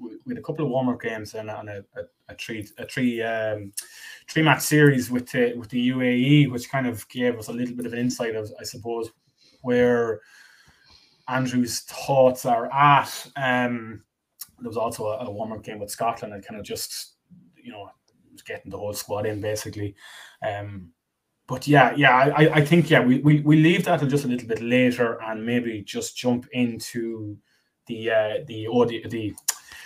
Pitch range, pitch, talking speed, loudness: 110-130 Hz, 120 Hz, 195 wpm, -23 LUFS